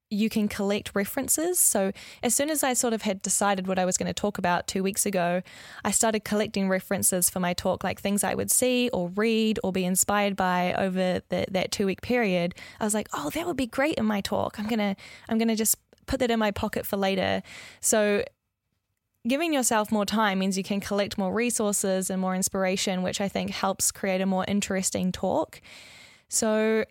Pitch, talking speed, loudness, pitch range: 200 Hz, 210 wpm, -26 LUFS, 185-220 Hz